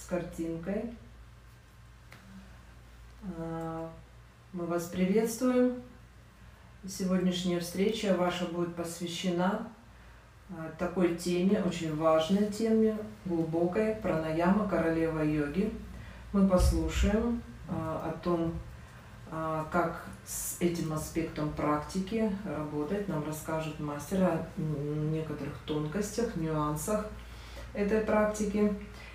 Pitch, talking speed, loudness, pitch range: 175 Hz, 80 wpm, -31 LUFS, 155-200 Hz